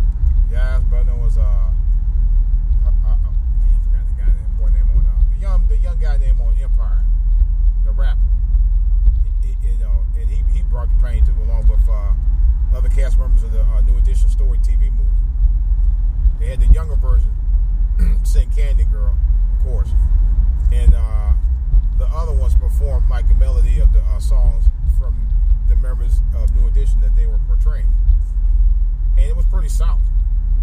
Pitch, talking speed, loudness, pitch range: 65 Hz, 170 wpm, -19 LUFS, 65-70 Hz